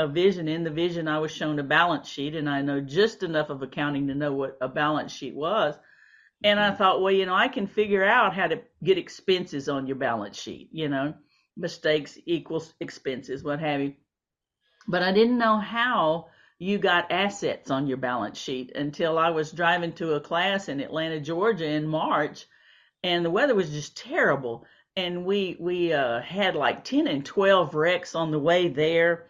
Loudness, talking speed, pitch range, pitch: -25 LUFS, 195 wpm, 145-190 Hz, 165 Hz